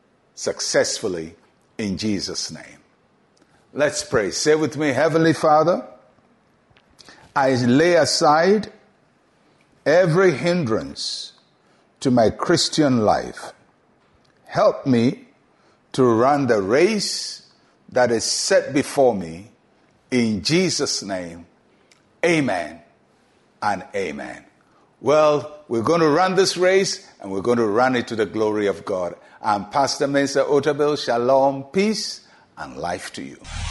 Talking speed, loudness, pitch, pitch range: 115 wpm, -20 LUFS, 145 Hz, 120-175 Hz